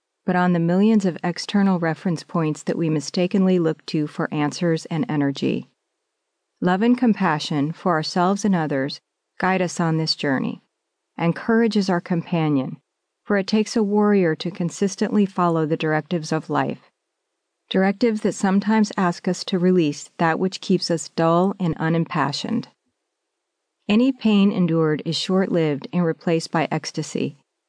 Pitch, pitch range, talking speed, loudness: 175 Hz, 160-195 Hz, 150 wpm, -21 LUFS